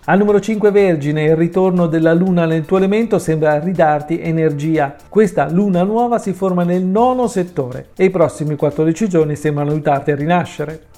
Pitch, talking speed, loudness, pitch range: 170 Hz, 170 wpm, -15 LUFS, 155-190 Hz